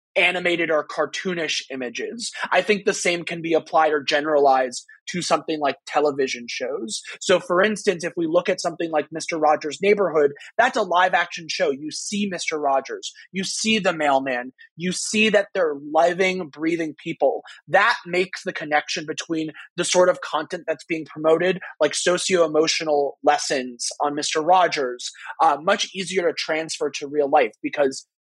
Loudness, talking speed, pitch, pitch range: -22 LUFS, 165 wpm, 165 Hz, 150-185 Hz